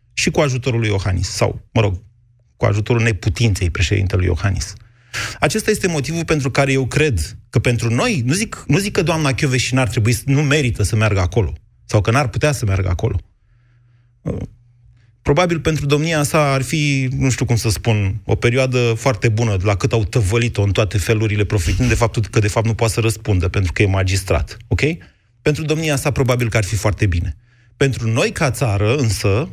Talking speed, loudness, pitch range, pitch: 195 wpm, -18 LUFS, 105-135 Hz, 115 Hz